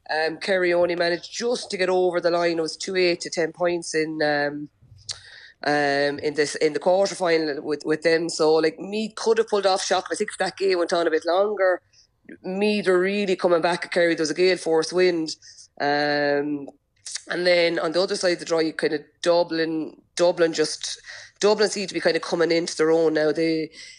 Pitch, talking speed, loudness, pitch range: 170 Hz, 215 wpm, -22 LUFS, 155-185 Hz